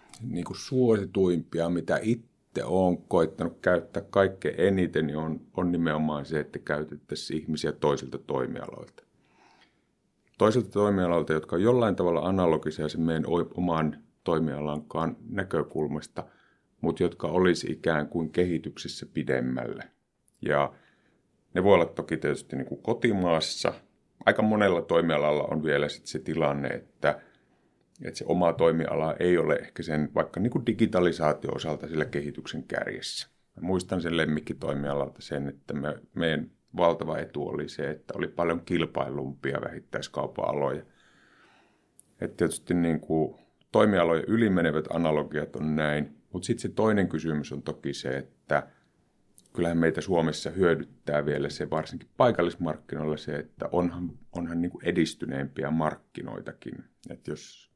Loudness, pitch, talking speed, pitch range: -28 LUFS, 80 Hz, 130 wpm, 75-90 Hz